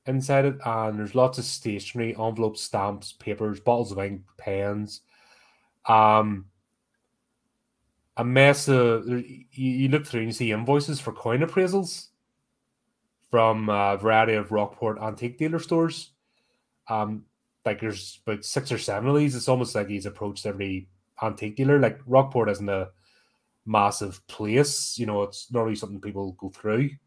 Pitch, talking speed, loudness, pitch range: 110 Hz, 150 wpm, -25 LUFS, 105-130 Hz